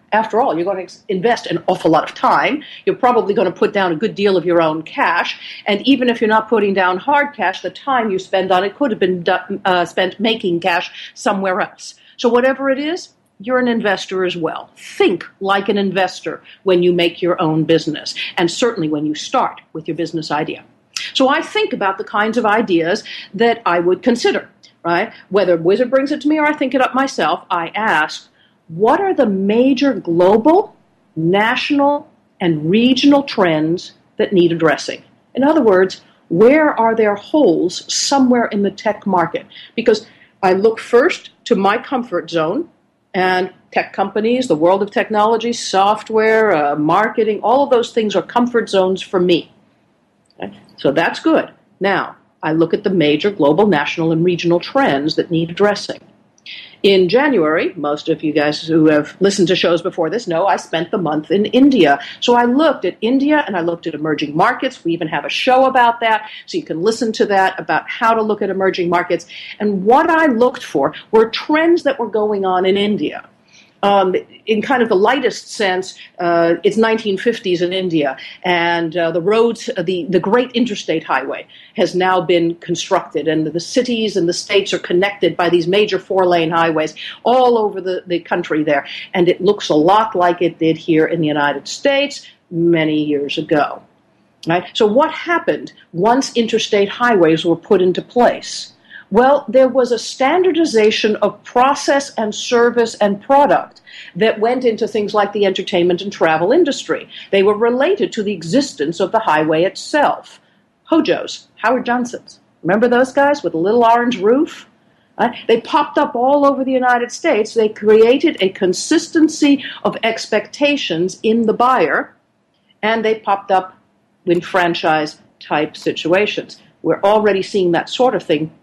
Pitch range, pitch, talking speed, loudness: 175-240 Hz, 205 Hz, 180 wpm, -15 LUFS